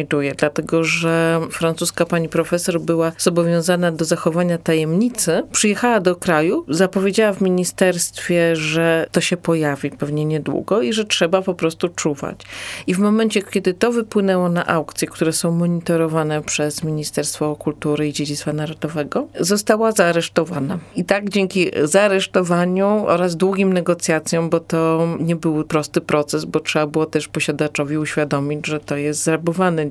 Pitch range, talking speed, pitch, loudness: 155-185 Hz, 140 wpm, 165 Hz, -18 LUFS